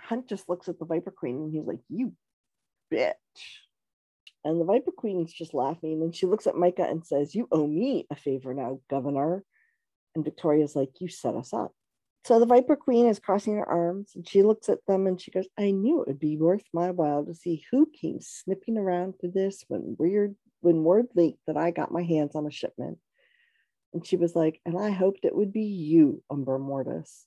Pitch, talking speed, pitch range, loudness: 175 Hz, 215 wpm, 155-205 Hz, -27 LUFS